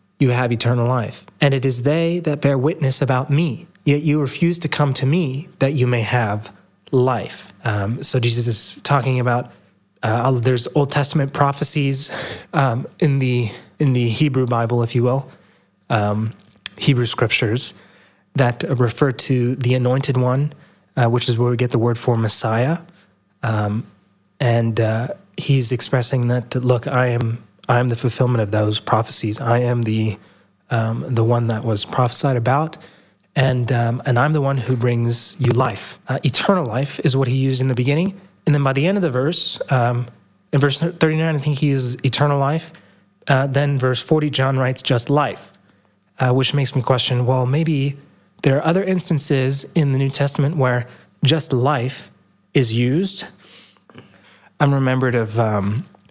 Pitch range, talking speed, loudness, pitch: 120-145 Hz, 170 wpm, -19 LUFS, 130 Hz